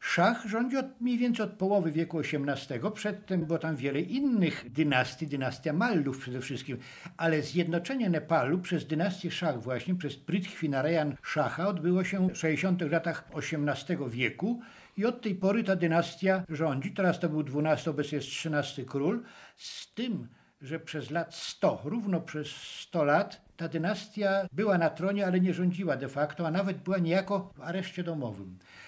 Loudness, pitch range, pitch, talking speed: -31 LUFS, 150-195 Hz, 170 Hz, 160 wpm